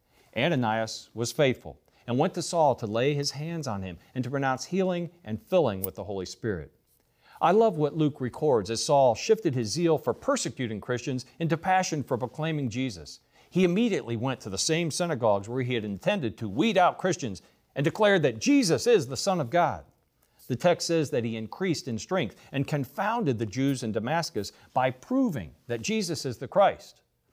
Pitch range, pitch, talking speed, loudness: 115-165 Hz, 135 Hz, 190 wpm, -27 LUFS